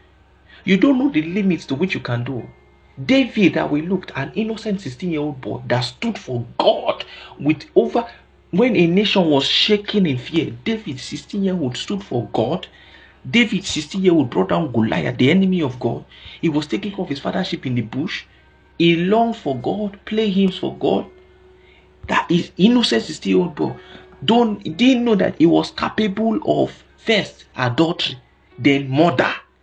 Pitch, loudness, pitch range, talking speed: 170 Hz, -19 LUFS, 135-210 Hz, 175 wpm